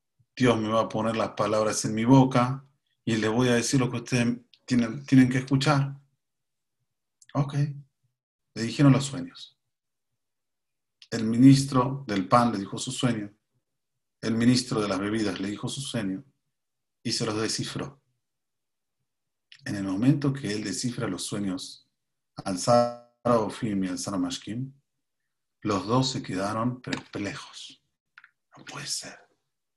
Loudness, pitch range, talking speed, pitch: -26 LUFS, 110-135 Hz, 140 wpm, 125 Hz